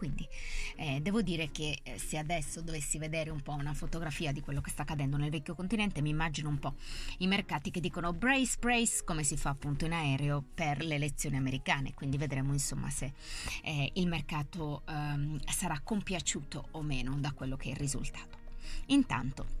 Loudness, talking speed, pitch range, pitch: -35 LUFS, 185 wpm, 140-170 Hz, 150 Hz